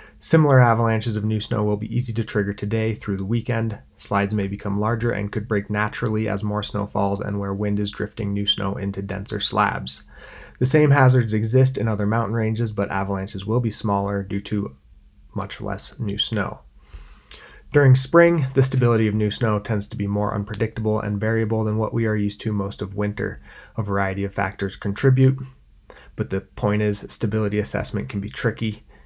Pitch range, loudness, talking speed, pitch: 100-115 Hz, -22 LUFS, 190 wpm, 105 Hz